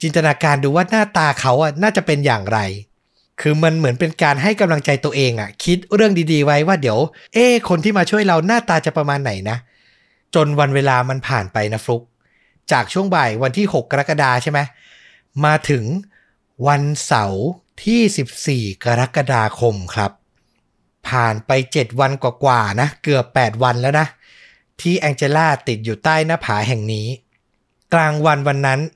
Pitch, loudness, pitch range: 145 Hz, -17 LUFS, 120-160 Hz